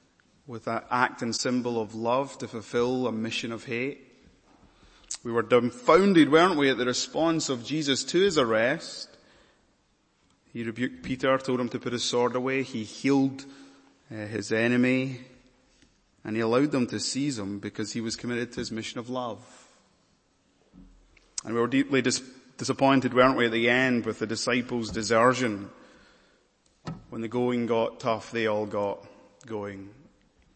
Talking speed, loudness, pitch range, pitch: 160 wpm, -26 LUFS, 110-130 Hz, 120 Hz